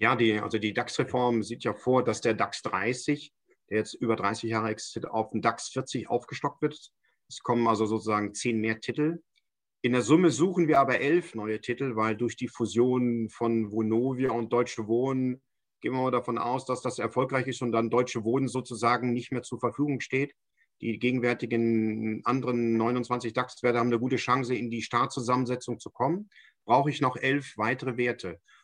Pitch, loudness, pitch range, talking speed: 120 Hz, -28 LUFS, 115-130 Hz, 185 wpm